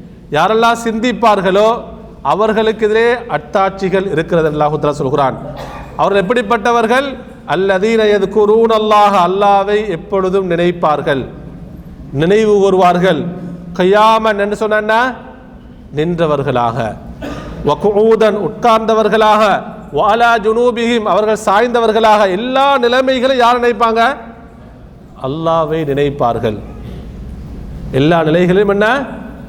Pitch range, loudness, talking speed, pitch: 165-225 Hz, -12 LUFS, 75 wpm, 205 Hz